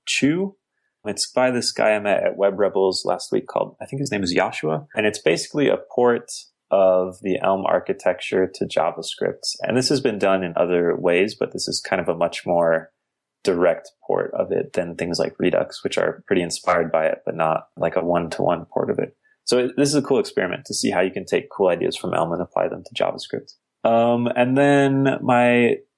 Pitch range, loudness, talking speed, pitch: 90-130 Hz, -21 LUFS, 215 wpm, 110 Hz